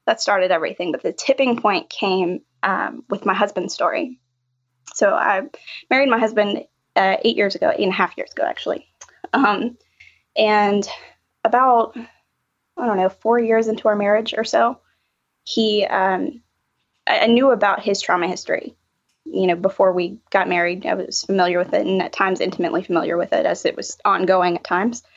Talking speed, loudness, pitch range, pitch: 180 wpm, -19 LUFS, 185-240 Hz, 210 Hz